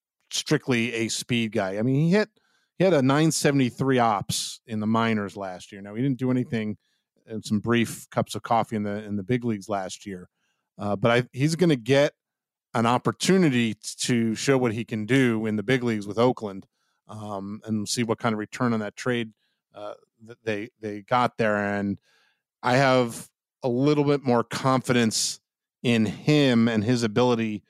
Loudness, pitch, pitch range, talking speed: -24 LUFS, 115 Hz, 105-130 Hz, 190 wpm